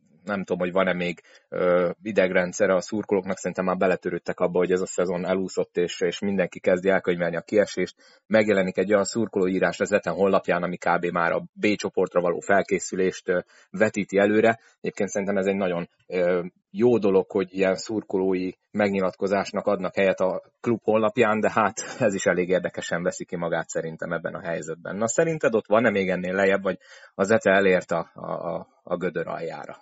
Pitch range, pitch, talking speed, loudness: 90-105 Hz, 95 Hz, 180 wpm, -24 LUFS